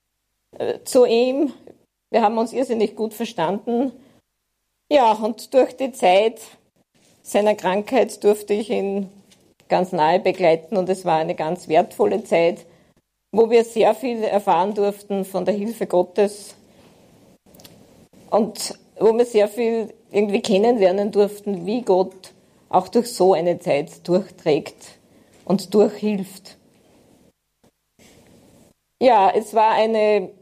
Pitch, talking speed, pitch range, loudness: 205 Hz, 120 wpm, 185-225 Hz, -20 LUFS